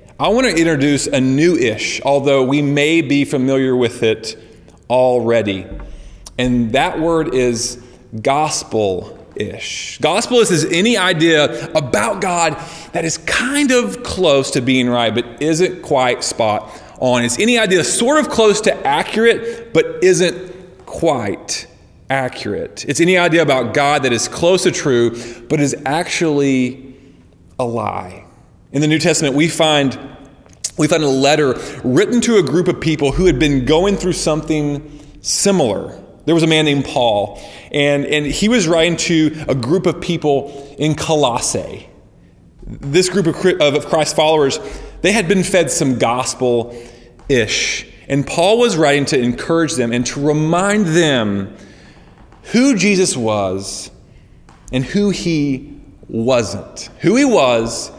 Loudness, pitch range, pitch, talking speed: -15 LUFS, 125-175 Hz, 150 Hz, 145 wpm